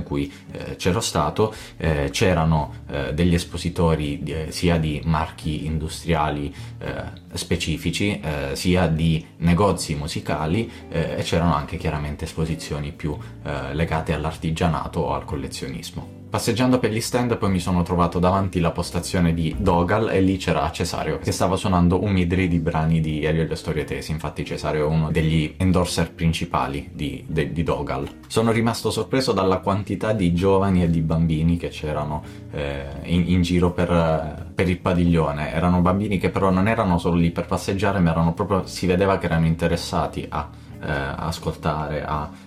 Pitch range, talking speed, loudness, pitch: 80-95 Hz, 155 wpm, -22 LUFS, 85 Hz